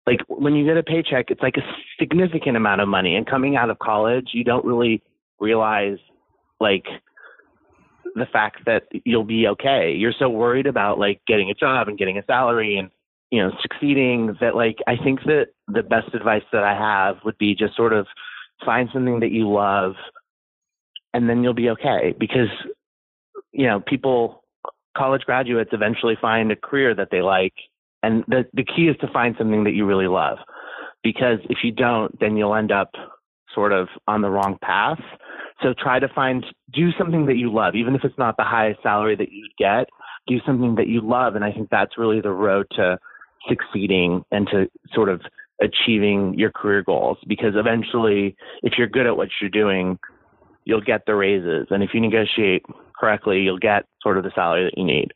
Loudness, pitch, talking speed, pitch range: -20 LUFS, 115 Hz, 195 wpm, 105-130 Hz